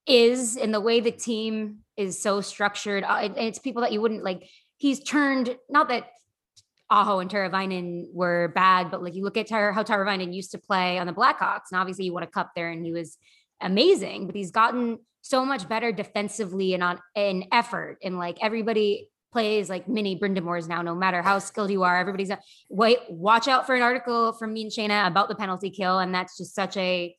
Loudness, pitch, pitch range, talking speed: -25 LUFS, 205 Hz, 185-230 Hz, 205 wpm